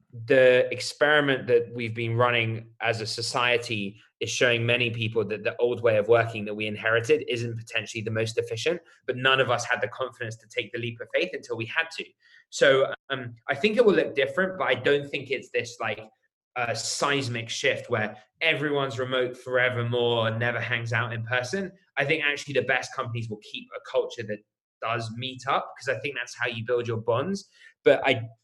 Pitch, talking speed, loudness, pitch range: 125 Hz, 205 wpm, -26 LUFS, 115-150 Hz